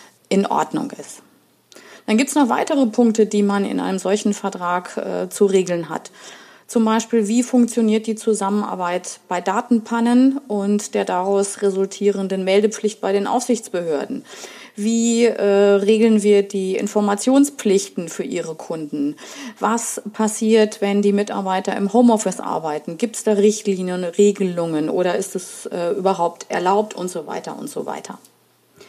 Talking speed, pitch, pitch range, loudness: 145 wpm, 205 Hz, 190-225 Hz, -19 LUFS